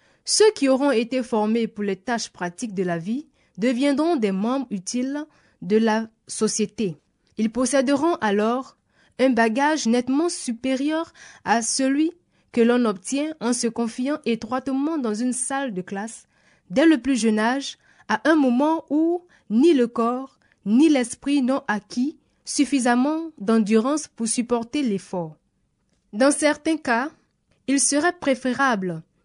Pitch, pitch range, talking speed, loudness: 250 Hz, 225-285 Hz, 135 wpm, -22 LUFS